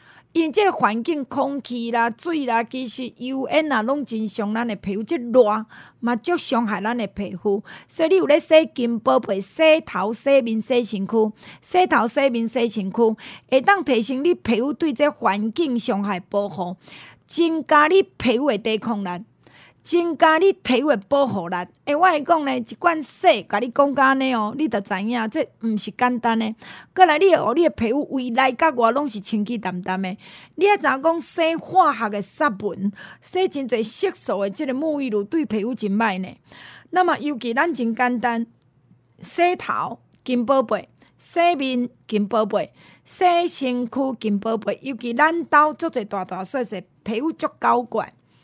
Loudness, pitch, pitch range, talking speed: -21 LUFS, 245 Hz, 220-300 Hz, 250 characters per minute